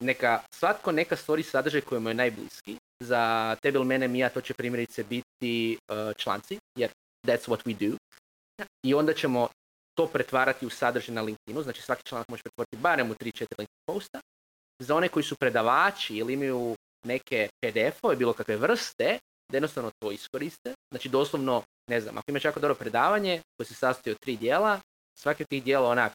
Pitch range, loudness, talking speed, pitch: 115-145 Hz, -29 LUFS, 185 wpm, 125 Hz